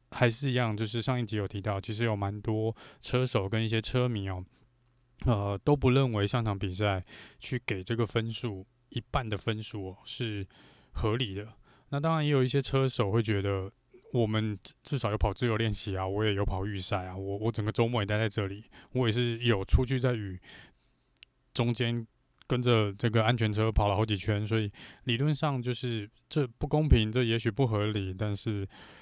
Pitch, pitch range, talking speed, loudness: 115 Hz, 105-125 Hz, 275 characters per minute, -30 LUFS